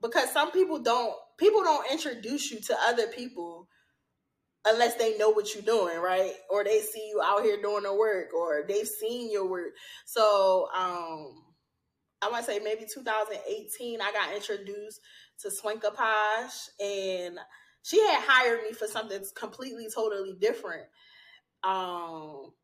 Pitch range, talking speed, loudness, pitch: 200-235 Hz, 150 wpm, -28 LUFS, 215 Hz